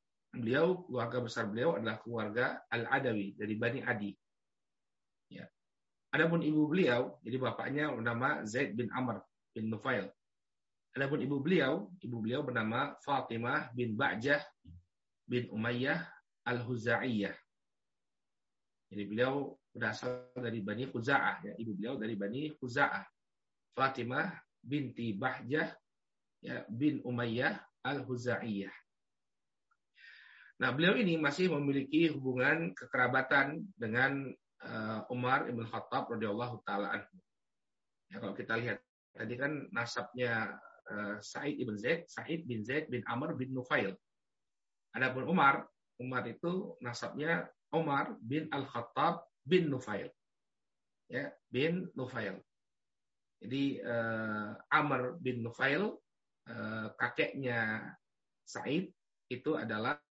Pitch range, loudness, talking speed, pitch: 115-140 Hz, -35 LUFS, 105 wpm, 125 Hz